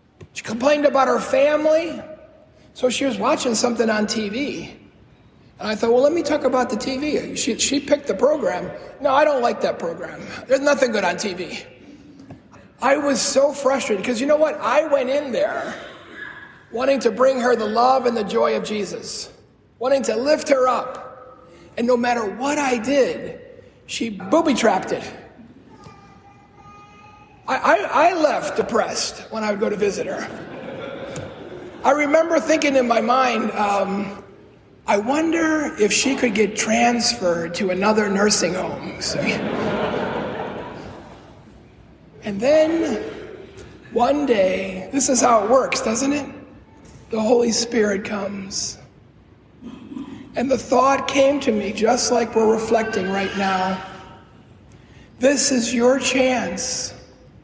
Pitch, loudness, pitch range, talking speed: 255 Hz, -20 LUFS, 220-280 Hz, 140 wpm